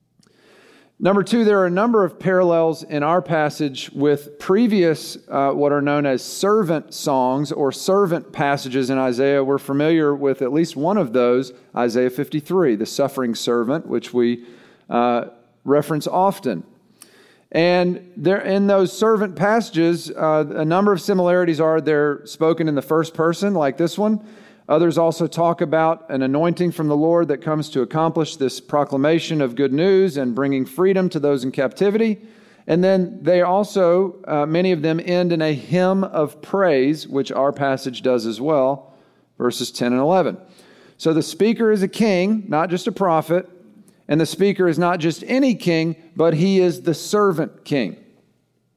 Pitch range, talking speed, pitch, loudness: 140-185 Hz, 170 wpm, 160 Hz, -19 LUFS